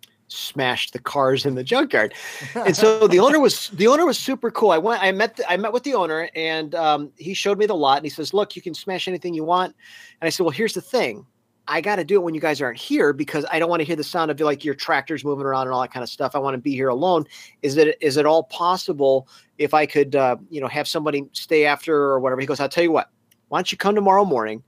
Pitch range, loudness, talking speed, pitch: 140-180 Hz, -20 LUFS, 280 wpm, 155 Hz